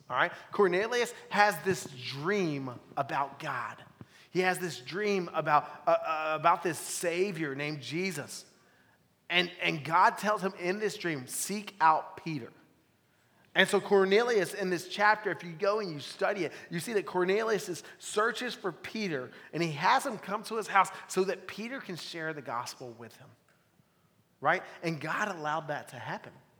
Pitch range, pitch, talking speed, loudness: 155-200 Hz, 180 Hz, 170 wpm, -31 LUFS